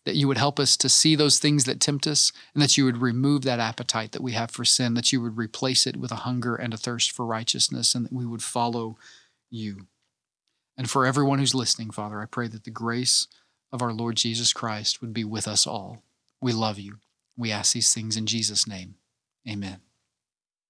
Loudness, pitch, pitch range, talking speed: -23 LUFS, 120 Hz, 110-130 Hz, 215 wpm